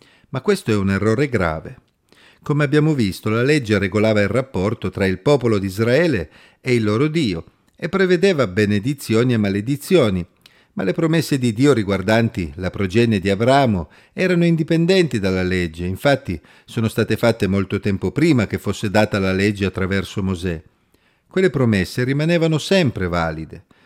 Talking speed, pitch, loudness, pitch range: 155 wpm, 110 Hz, -19 LUFS, 95-145 Hz